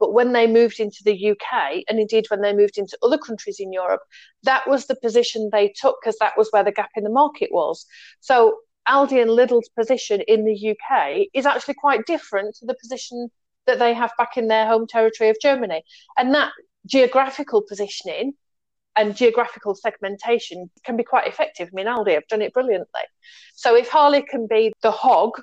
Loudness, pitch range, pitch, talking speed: -20 LUFS, 215-270 Hz, 235 Hz, 195 wpm